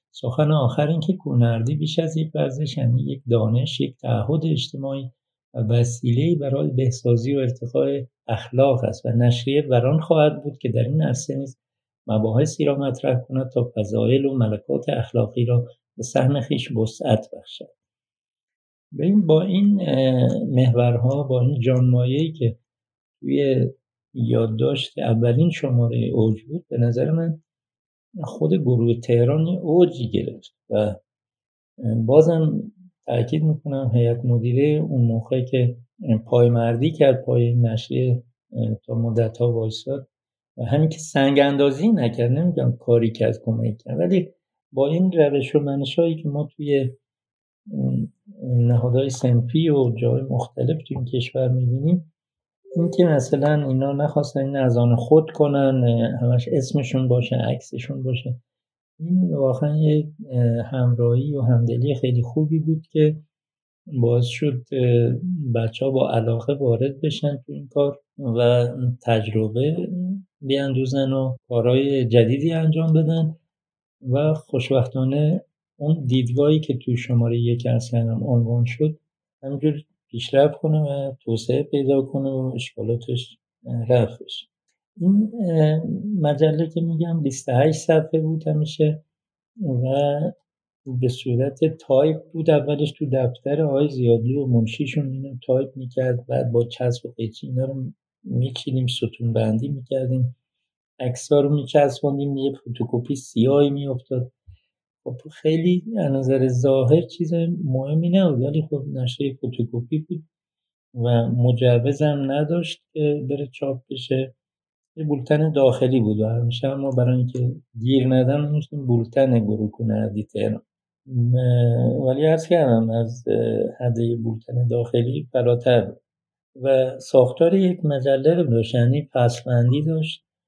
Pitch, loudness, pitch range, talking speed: 130 Hz, -21 LUFS, 120-150 Hz, 130 wpm